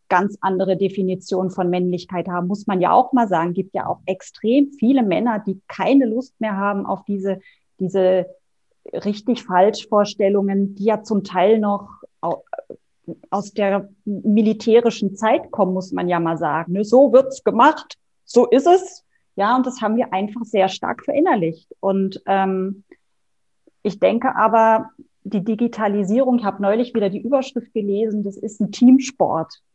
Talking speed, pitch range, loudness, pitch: 155 wpm, 190-240 Hz, -19 LUFS, 205 Hz